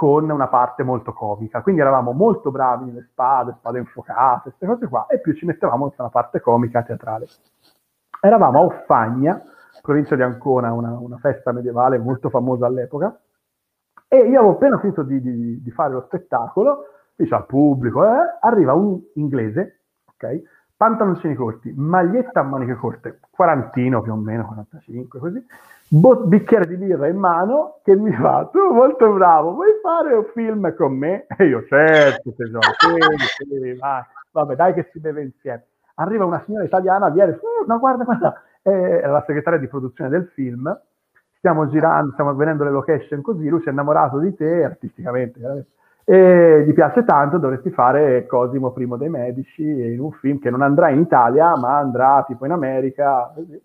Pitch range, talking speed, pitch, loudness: 125-185 Hz, 170 wpm, 145 Hz, -17 LUFS